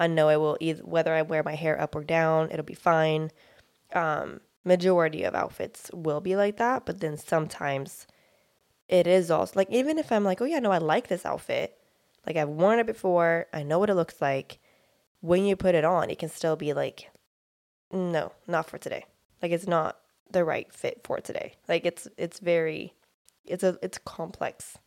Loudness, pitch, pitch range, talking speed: -27 LUFS, 165 Hz, 155-185 Hz, 200 wpm